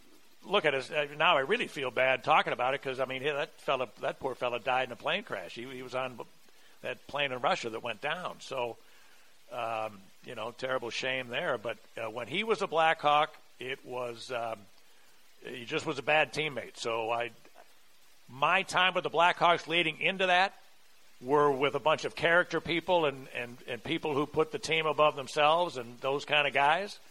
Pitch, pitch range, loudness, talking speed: 145 Hz, 125-160 Hz, -30 LUFS, 205 wpm